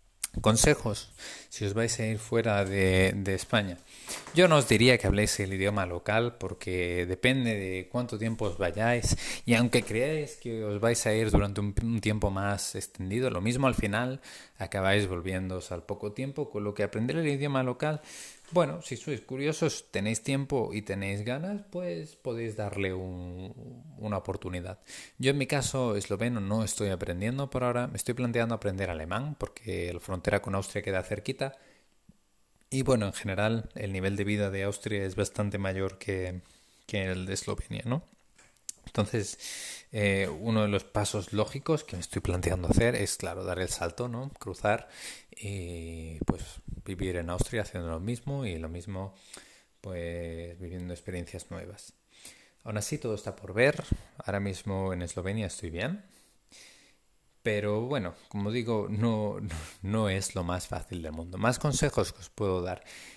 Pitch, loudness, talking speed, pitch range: 105 Hz, -31 LUFS, 165 wpm, 95-120 Hz